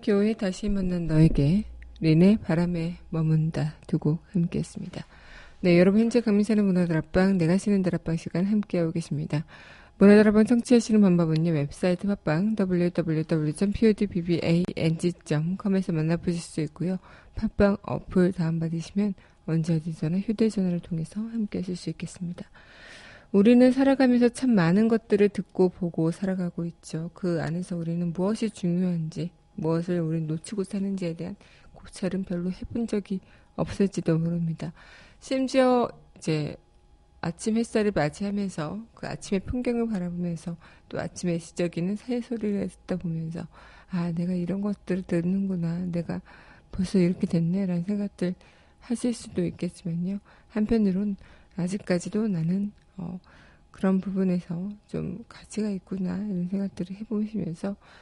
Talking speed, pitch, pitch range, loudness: 330 characters per minute, 180 Hz, 170-205 Hz, -26 LUFS